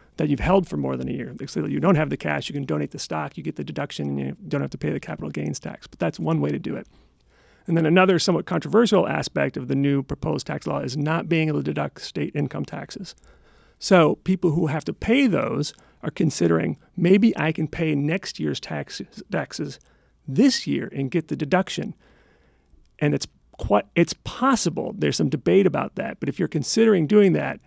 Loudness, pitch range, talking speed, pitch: -23 LUFS, 135-185 Hz, 215 wpm, 155 Hz